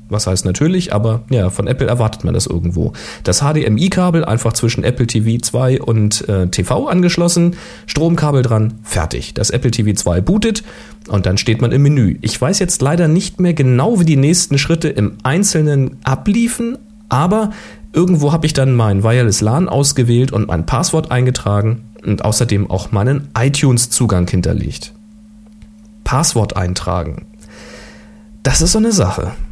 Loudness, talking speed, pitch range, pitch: -14 LUFS, 150 wpm, 105-160 Hz, 125 Hz